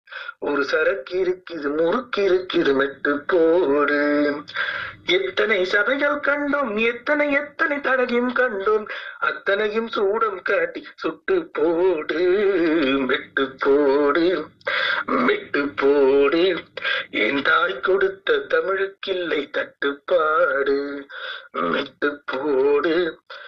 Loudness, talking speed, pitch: -21 LUFS, 75 wpm, 255 Hz